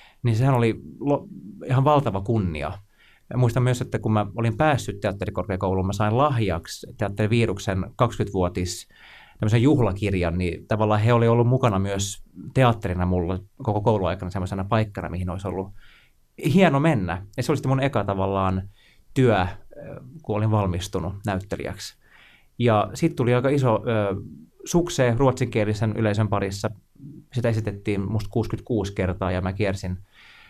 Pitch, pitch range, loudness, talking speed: 105 Hz, 95-120 Hz, -24 LUFS, 130 wpm